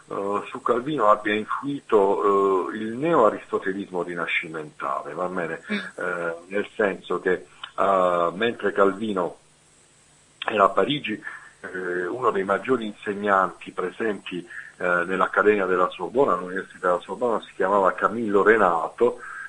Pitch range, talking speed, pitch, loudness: 95-110 Hz, 100 wpm, 100 Hz, -23 LUFS